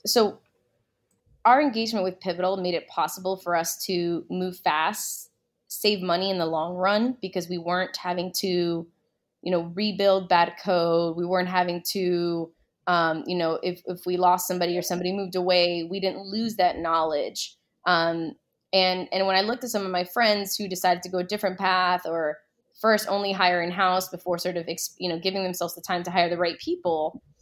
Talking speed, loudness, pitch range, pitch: 195 wpm, -25 LUFS, 170-190 Hz, 180 Hz